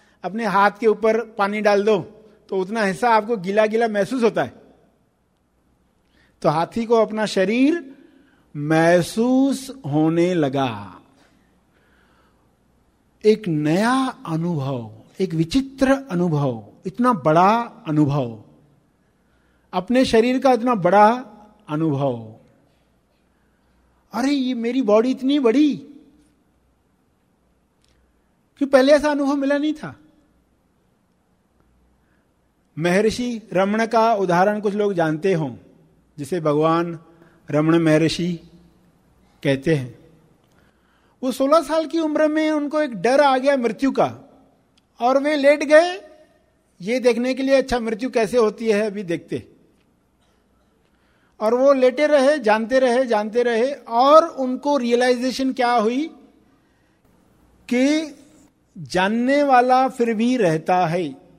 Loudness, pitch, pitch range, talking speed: -19 LUFS, 215 Hz, 165-260 Hz, 110 wpm